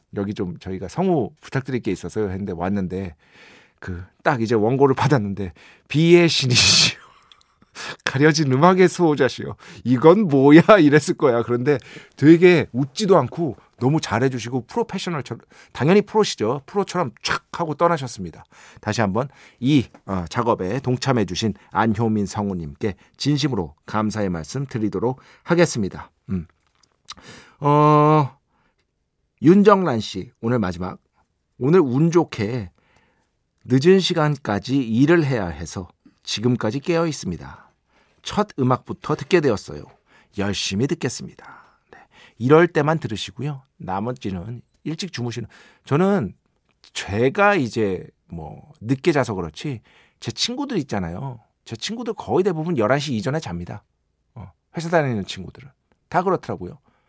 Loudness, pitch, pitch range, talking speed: -20 LUFS, 130 Hz, 105-165 Hz, 285 characters per minute